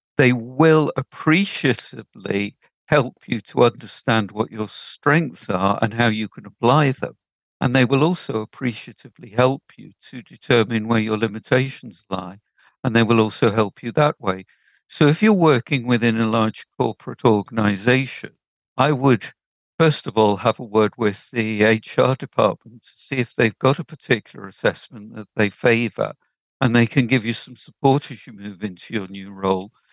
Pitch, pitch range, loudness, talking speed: 115 Hz, 110-130 Hz, -20 LUFS, 170 wpm